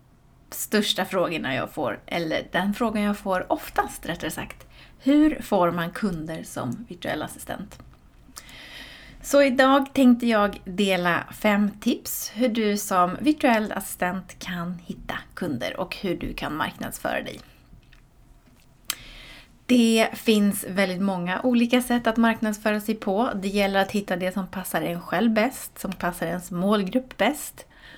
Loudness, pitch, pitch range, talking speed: -24 LUFS, 205 Hz, 185-235 Hz, 140 wpm